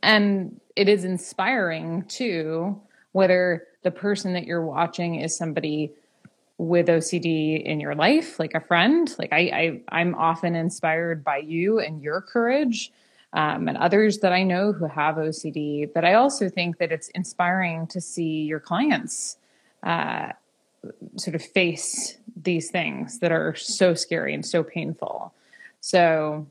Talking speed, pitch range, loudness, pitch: 150 wpm, 165-200 Hz, -24 LUFS, 175 Hz